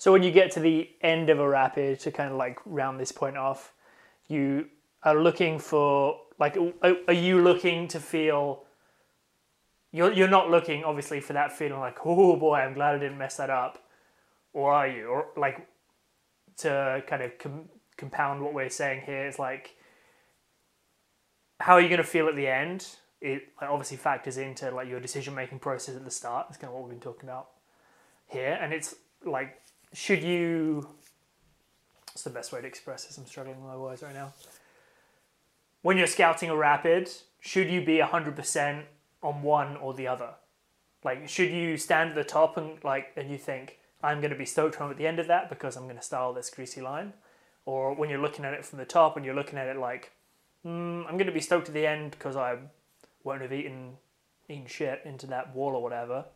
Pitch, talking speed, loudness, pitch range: 145 Hz, 200 wpm, -27 LUFS, 135-165 Hz